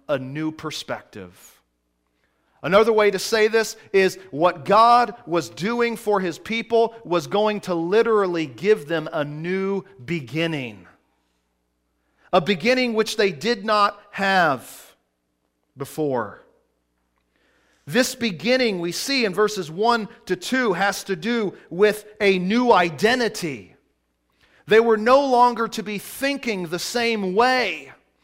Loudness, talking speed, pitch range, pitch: -21 LUFS, 125 wpm, 155-225 Hz, 195 Hz